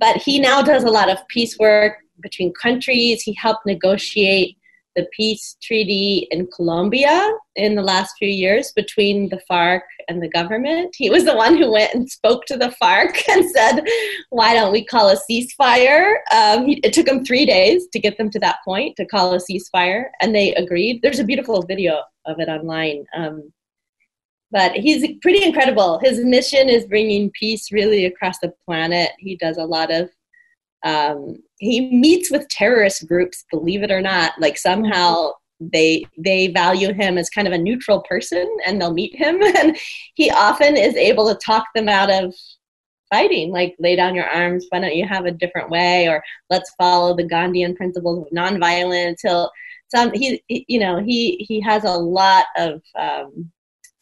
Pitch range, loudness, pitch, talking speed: 180-250 Hz, -16 LUFS, 205 Hz, 185 wpm